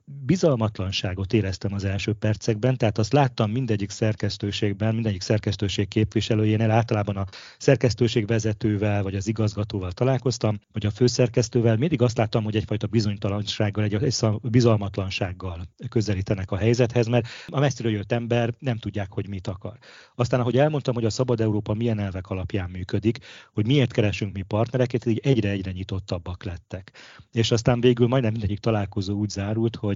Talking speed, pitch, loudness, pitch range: 150 wpm, 110 Hz, -24 LUFS, 100-120 Hz